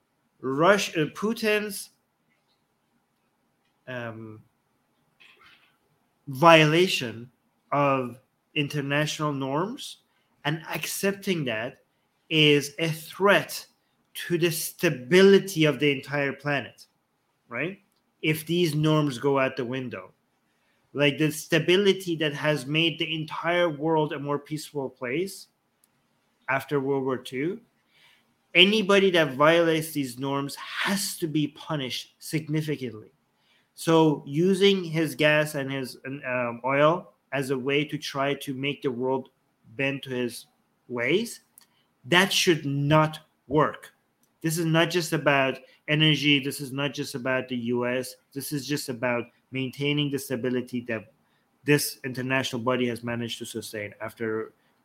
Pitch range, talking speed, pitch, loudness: 130-160 Hz, 120 wpm, 145 Hz, -25 LUFS